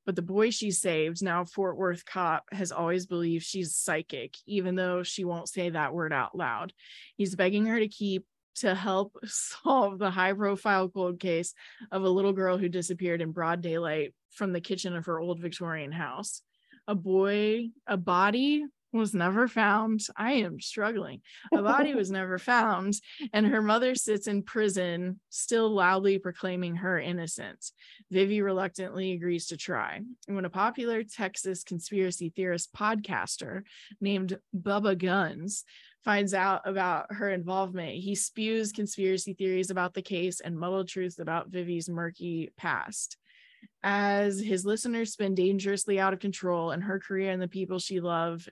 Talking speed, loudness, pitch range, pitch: 160 wpm, -30 LUFS, 180-205 Hz, 190 Hz